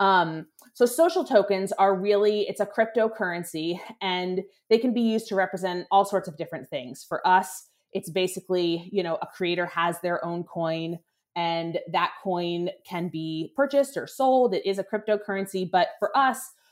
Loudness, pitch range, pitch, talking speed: -26 LUFS, 175-210 Hz, 190 Hz, 170 wpm